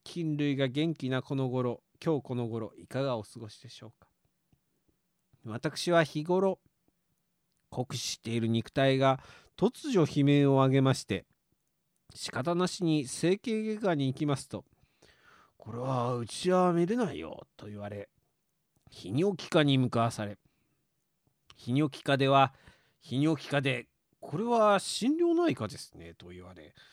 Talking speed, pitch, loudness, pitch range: 265 characters per minute, 140 Hz, -30 LUFS, 120-170 Hz